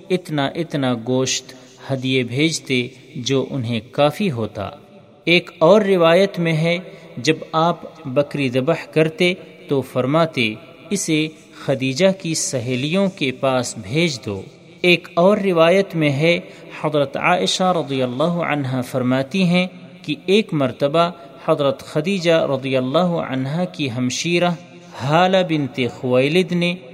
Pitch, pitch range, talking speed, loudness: 155 Hz, 130-175 Hz, 125 wpm, -19 LUFS